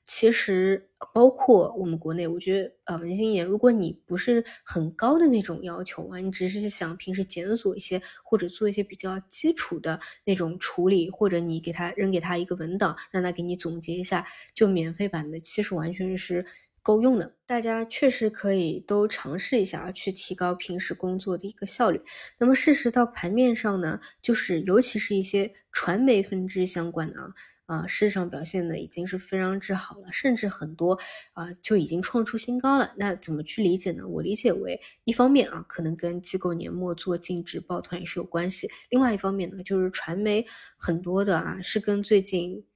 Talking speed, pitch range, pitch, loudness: 300 characters per minute, 175-210 Hz, 190 Hz, -26 LUFS